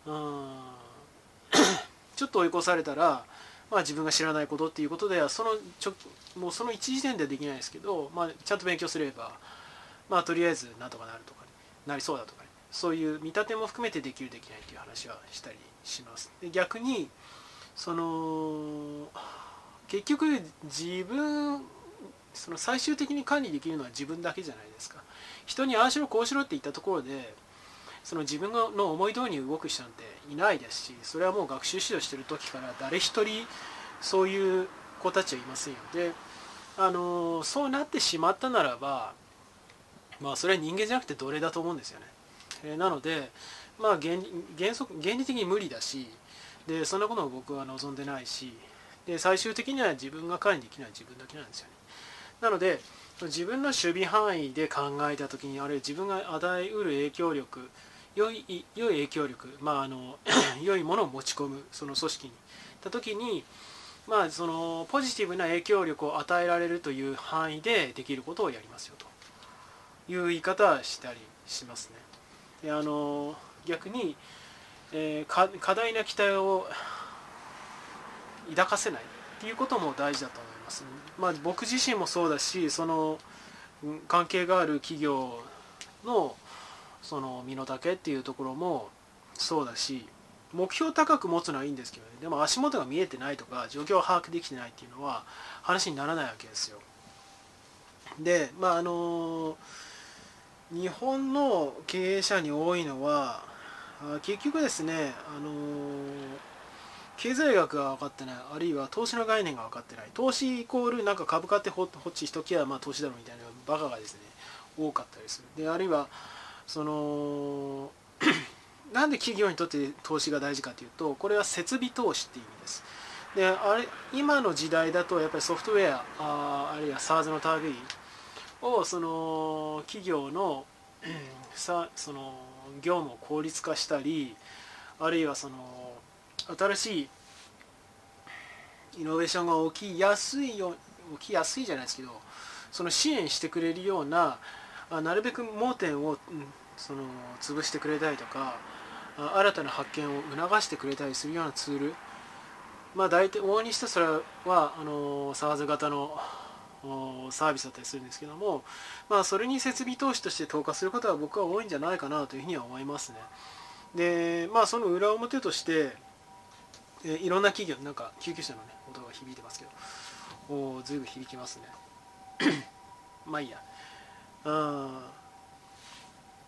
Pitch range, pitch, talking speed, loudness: 145-195 Hz, 165 Hz, 320 characters per minute, -31 LUFS